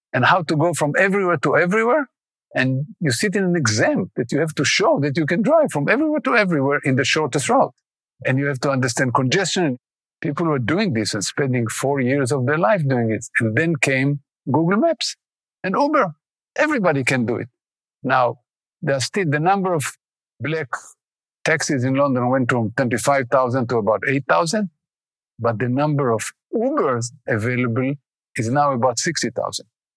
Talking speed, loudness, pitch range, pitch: 180 wpm, -20 LUFS, 125-165 Hz, 140 Hz